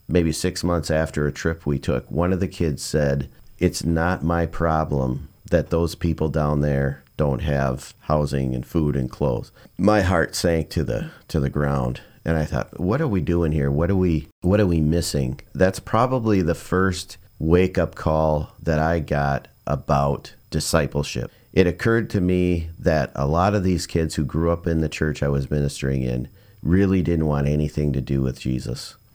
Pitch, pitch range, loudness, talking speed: 80 Hz, 70-90 Hz, -22 LUFS, 190 wpm